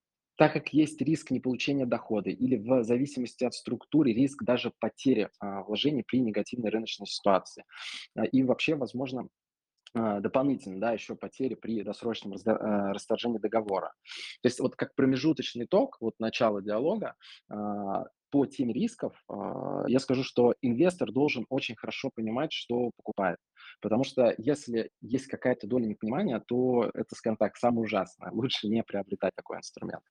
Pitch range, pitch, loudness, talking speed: 110-130 Hz, 120 Hz, -30 LUFS, 155 wpm